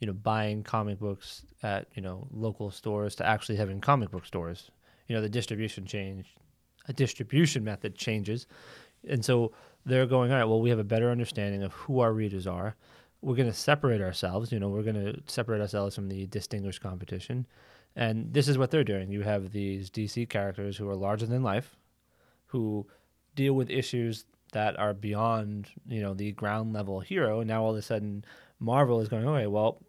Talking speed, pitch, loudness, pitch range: 200 wpm, 110 Hz, -30 LUFS, 100-120 Hz